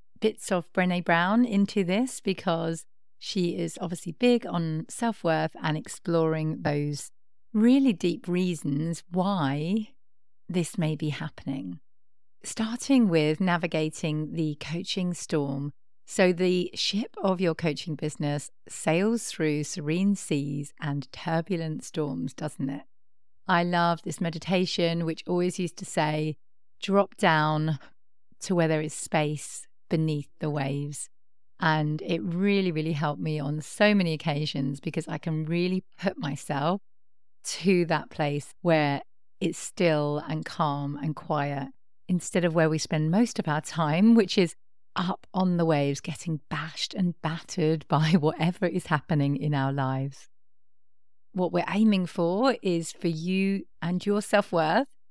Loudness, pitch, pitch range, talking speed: -27 LUFS, 160 Hz, 145-180 Hz, 140 wpm